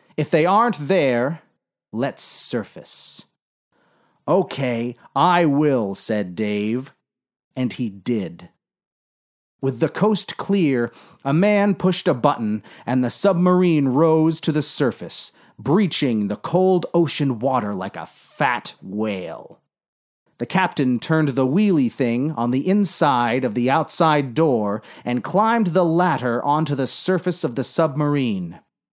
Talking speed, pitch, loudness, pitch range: 130 wpm, 145 Hz, -20 LUFS, 120-175 Hz